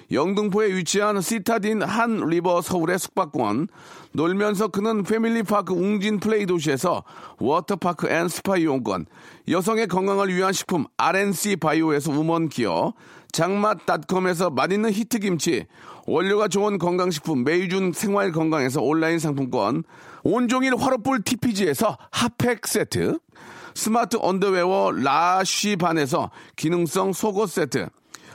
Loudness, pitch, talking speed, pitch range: -22 LUFS, 195 Hz, 300 characters per minute, 175-215 Hz